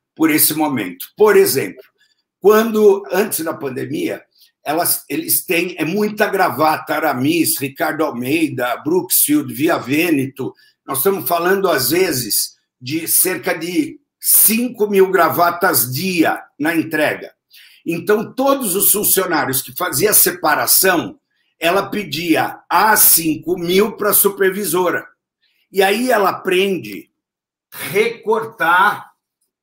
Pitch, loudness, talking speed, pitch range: 195 Hz, -15 LUFS, 115 wpm, 170-275 Hz